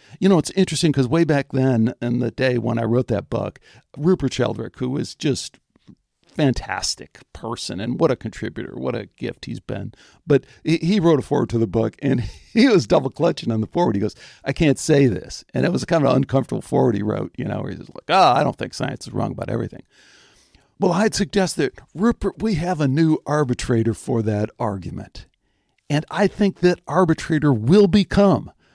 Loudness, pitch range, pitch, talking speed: -20 LUFS, 115-175 Hz, 135 Hz, 205 wpm